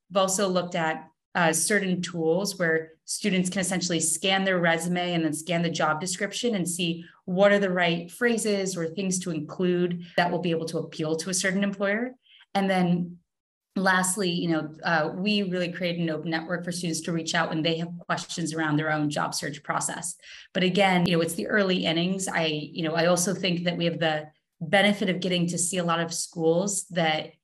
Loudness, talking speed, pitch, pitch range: -26 LUFS, 210 wpm, 175 Hz, 165-190 Hz